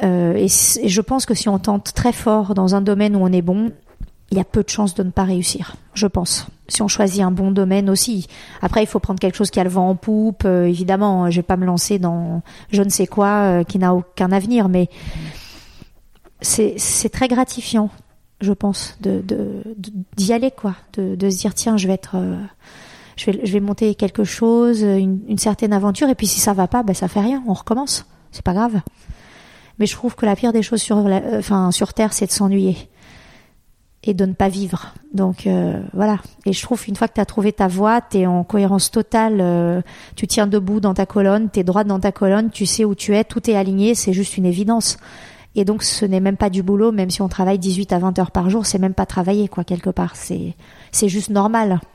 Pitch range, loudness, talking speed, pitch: 190-215 Hz, -18 LUFS, 240 wpm, 200 Hz